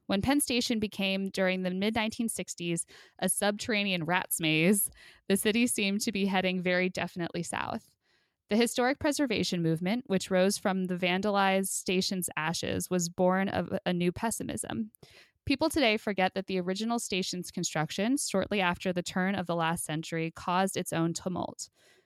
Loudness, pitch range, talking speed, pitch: -30 LUFS, 180-215 Hz, 160 wpm, 190 Hz